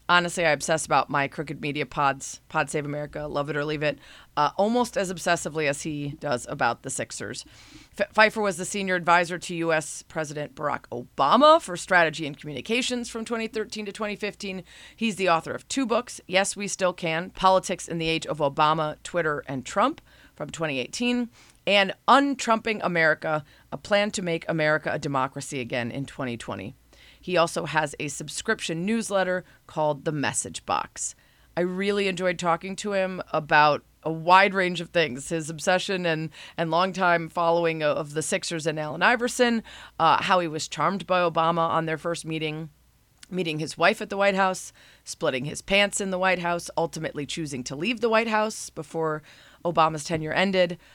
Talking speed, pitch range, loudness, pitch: 175 wpm, 155-195 Hz, -25 LUFS, 170 Hz